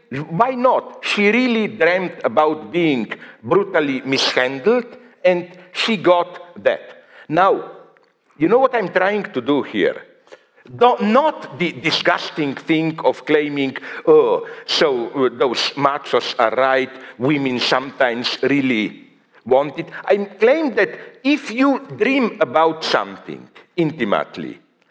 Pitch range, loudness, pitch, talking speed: 150-250 Hz, -18 LUFS, 180 Hz, 115 wpm